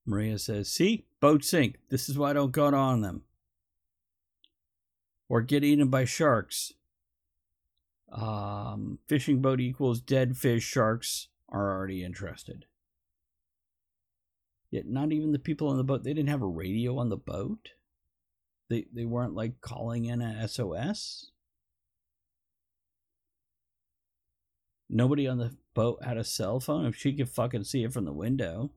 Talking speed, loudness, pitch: 145 wpm, -29 LUFS, 110 Hz